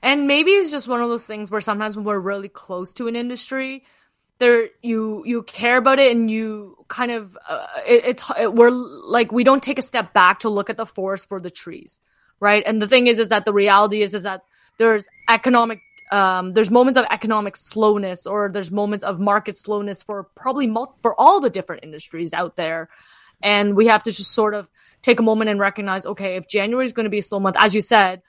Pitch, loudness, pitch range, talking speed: 215 Hz, -18 LUFS, 200-240 Hz, 230 wpm